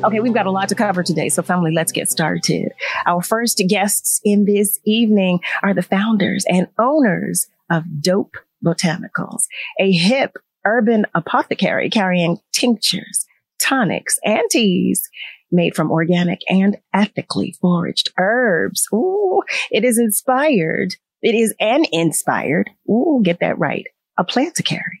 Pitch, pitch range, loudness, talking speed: 195 Hz, 175-225 Hz, -17 LUFS, 140 wpm